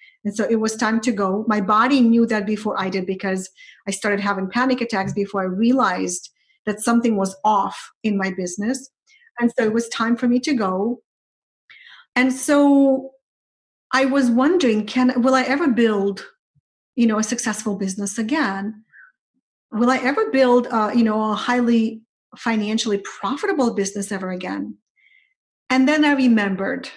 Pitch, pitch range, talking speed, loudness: 230 Hz, 205-255 Hz, 160 wpm, -20 LUFS